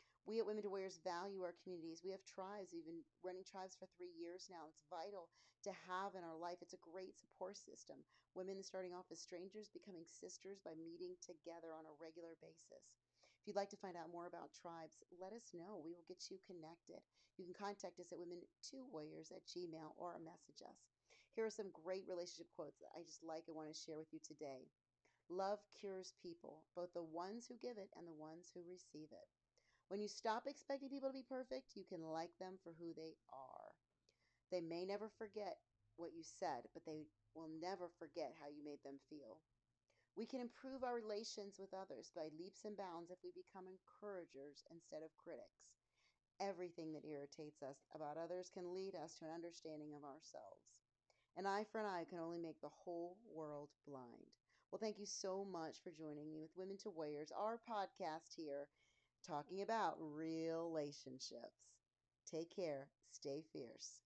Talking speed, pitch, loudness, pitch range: 190 wpm, 175 Hz, -52 LUFS, 160-195 Hz